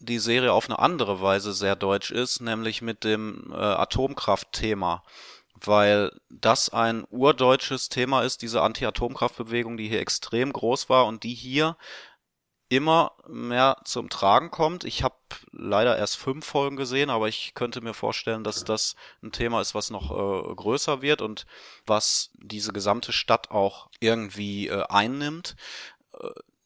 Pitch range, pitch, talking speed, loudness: 110-135 Hz, 120 Hz, 150 wpm, -25 LUFS